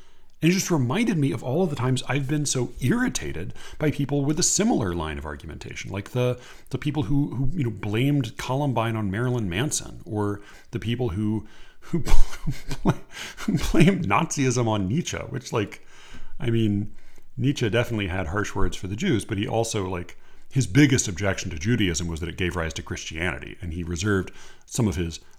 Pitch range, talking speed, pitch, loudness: 95-135 Hz, 185 wpm, 110 Hz, -25 LUFS